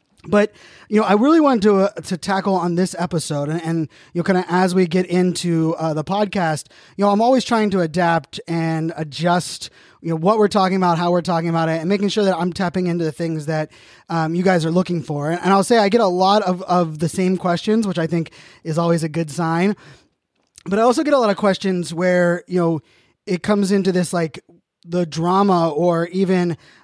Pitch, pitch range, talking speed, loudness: 180 Hz, 165-195 Hz, 230 wpm, -19 LUFS